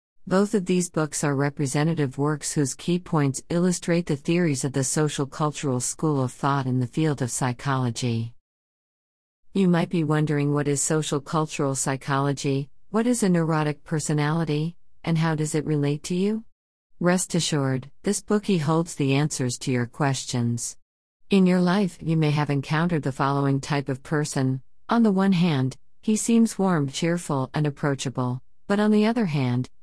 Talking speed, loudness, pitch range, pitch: 165 wpm, -24 LUFS, 135-170 Hz, 150 Hz